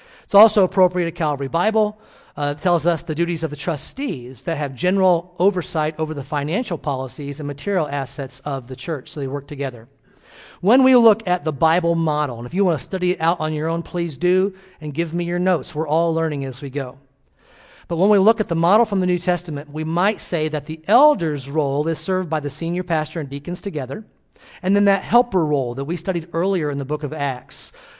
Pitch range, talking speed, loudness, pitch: 145-185 Hz, 225 wpm, -20 LUFS, 165 Hz